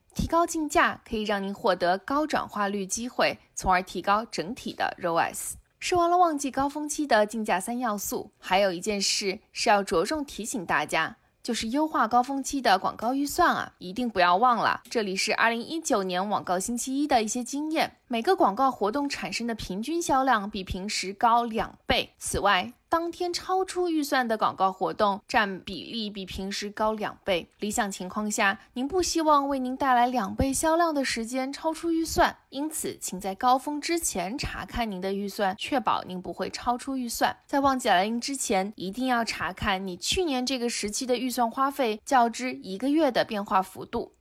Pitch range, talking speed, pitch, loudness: 200-280 Hz, 290 characters per minute, 240 Hz, -27 LUFS